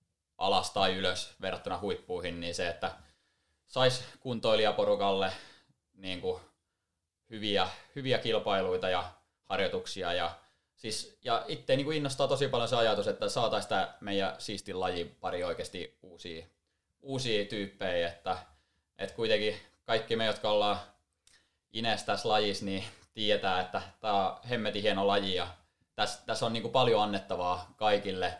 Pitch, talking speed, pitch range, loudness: 95 Hz, 135 wpm, 85-105 Hz, -32 LUFS